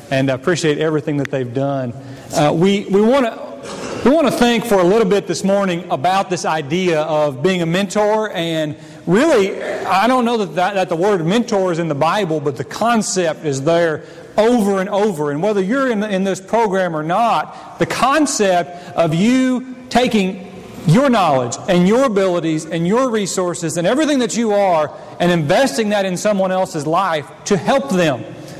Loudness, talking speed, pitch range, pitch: -16 LUFS, 185 wpm, 160-210 Hz, 185 Hz